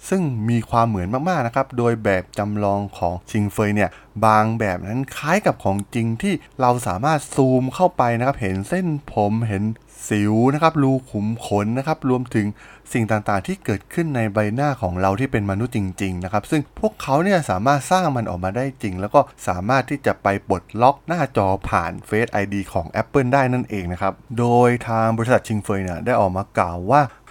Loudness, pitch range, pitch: -20 LUFS, 100-135 Hz, 115 Hz